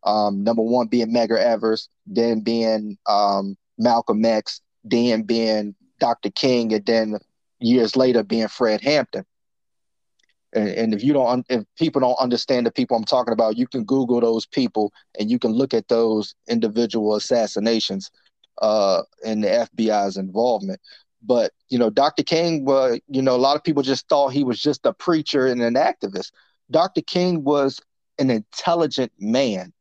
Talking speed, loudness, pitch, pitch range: 165 wpm, -21 LUFS, 115 Hz, 110-130 Hz